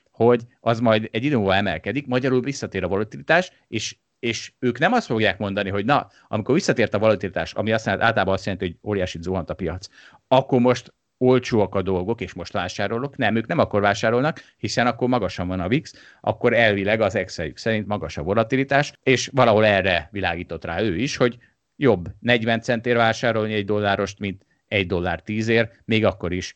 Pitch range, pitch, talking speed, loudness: 95-120 Hz, 110 Hz, 185 wpm, -22 LUFS